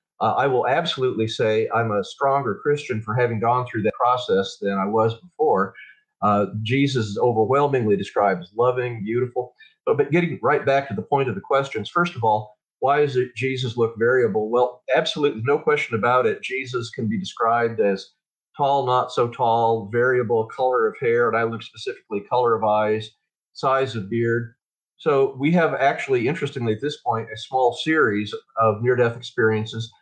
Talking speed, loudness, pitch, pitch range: 180 wpm, -22 LUFS, 125 Hz, 110-140 Hz